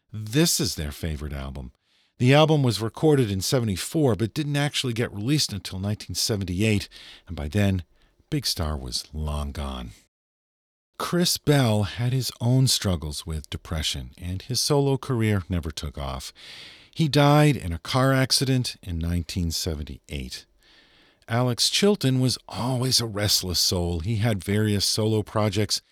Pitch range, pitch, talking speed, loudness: 85-130 Hz, 105 Hz, 140 wpm, -24 LUFS